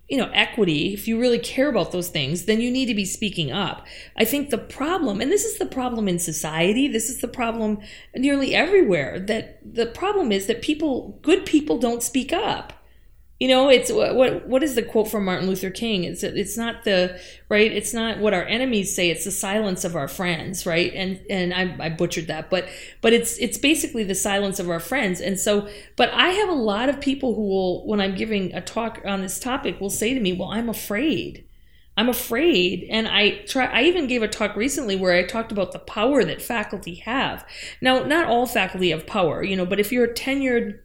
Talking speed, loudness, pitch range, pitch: 220 wpm, -22 LUFS, 190-250 Hz, 220 Hz